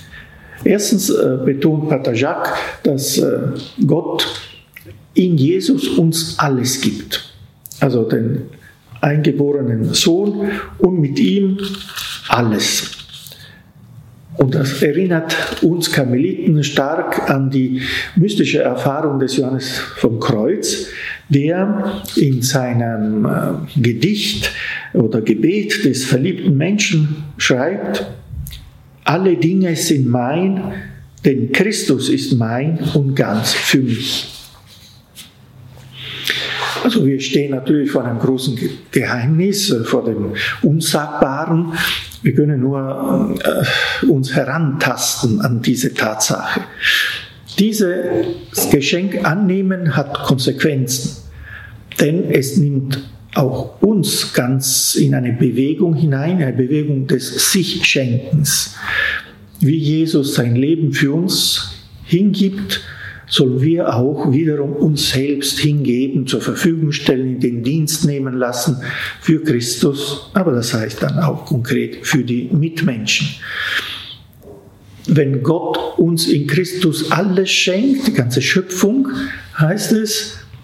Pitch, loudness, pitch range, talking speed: 145 Hz, -16 LUFS, 130-170 Hz, 105 wpm